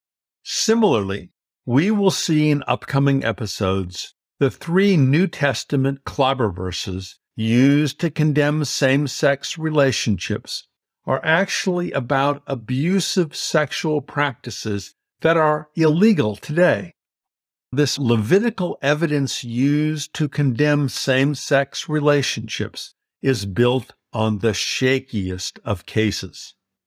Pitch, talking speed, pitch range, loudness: 140 Hz, 95 wpm, 120-155 Hz, -20 LUFS